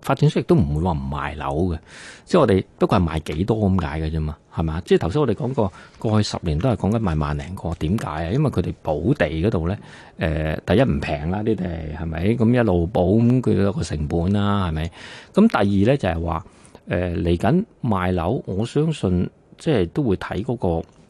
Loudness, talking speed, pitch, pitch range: -21 LUFS, 305 characters per minute, 90 Hz, 80-110 Hz